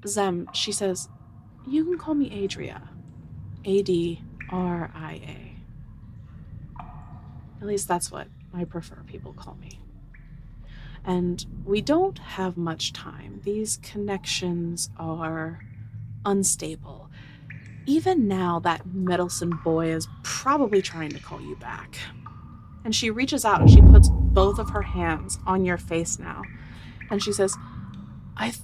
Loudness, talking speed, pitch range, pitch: -23 LUFS, 130 wpm, 140-195 Hz, 170 Hz